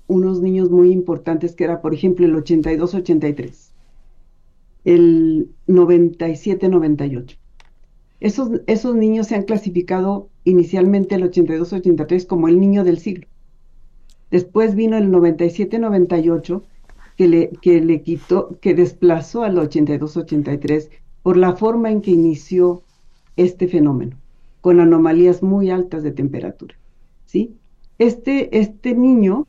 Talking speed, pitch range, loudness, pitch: 115 wpm, 165-195 Hz, -16 LUFS, 180 Hz